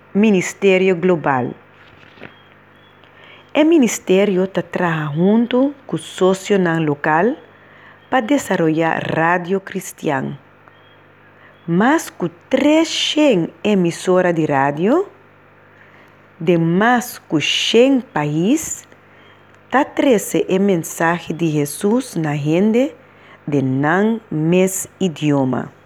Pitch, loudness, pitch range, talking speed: 180 Hz, -17 LUFS, 155-215 Hz, 80 wpm